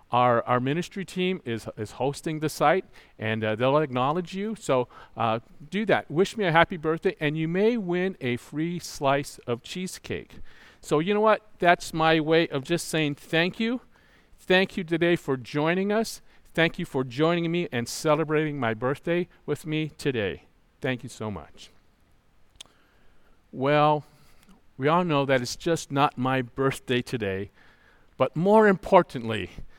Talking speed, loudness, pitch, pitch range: 160 wpm, -26 LUFS, 155 Hz, 130-175 Hz